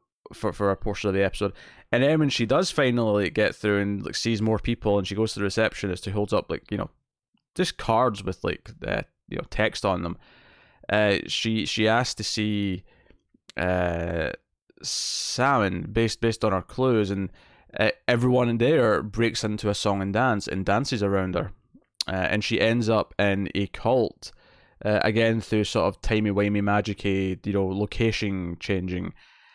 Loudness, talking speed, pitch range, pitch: -25 LUFS, 185 wpm, 100-115 Hz, 105 Hz